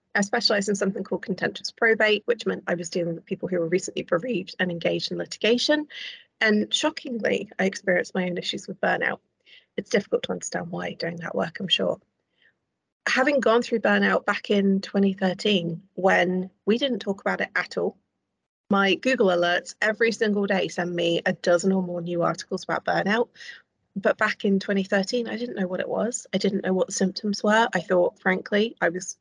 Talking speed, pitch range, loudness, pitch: 195 wpm, 185-220 Hz, -24 LUFS, 195 Hz